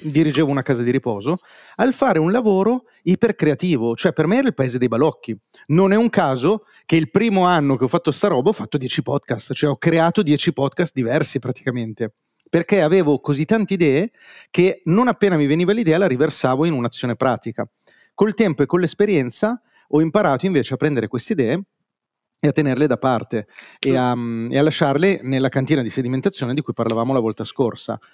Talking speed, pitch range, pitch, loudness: 190 wpm, 130-190 Hz, 155 Hz, -19 LUFS